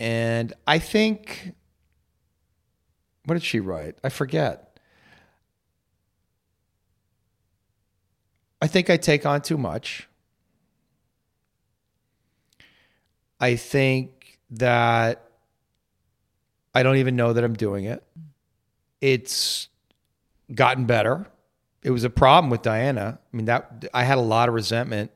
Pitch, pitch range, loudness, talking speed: 115 Hz, 100-125 Hz, -22 LUFS, 105 wpm